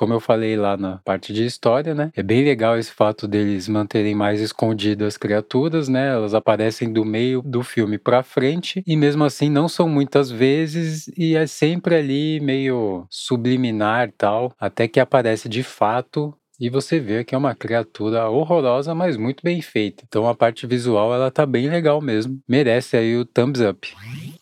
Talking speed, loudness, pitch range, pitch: 180 wpm, -20 LUFS, 110-145 Hz, 125 Hz